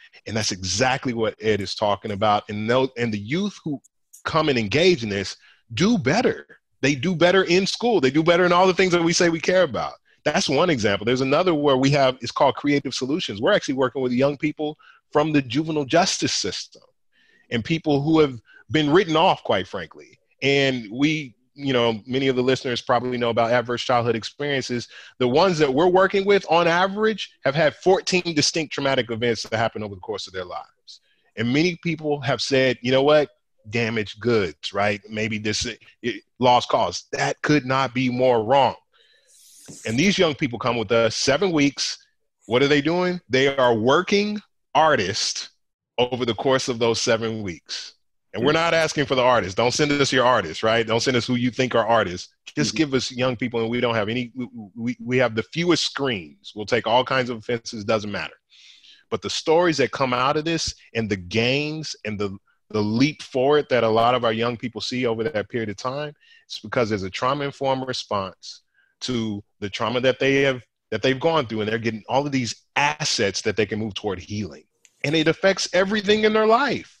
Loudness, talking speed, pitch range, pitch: -21 LUFS, 205 wpm, 115-155 Hz, 130 Hz